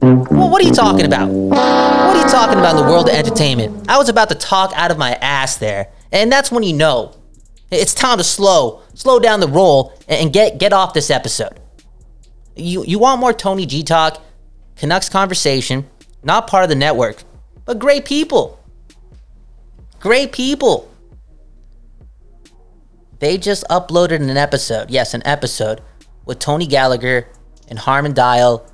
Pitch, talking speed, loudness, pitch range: 145 Hz, 165 wpm, -13 LUFS, 115-190 Hz